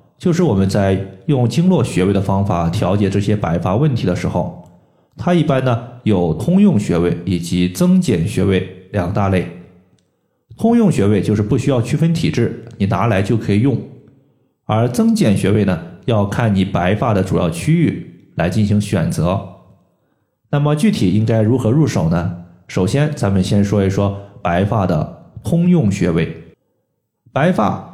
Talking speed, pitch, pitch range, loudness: 240 characters per minute, 105 Hz, 95-135 Hz, -16 LUFS